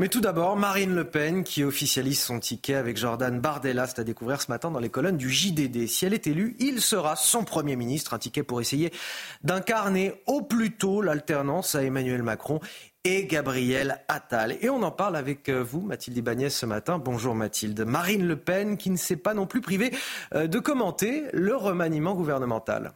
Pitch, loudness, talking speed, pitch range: 155 Hz, -27 LUFS, 195 wpm, 130-195 Hz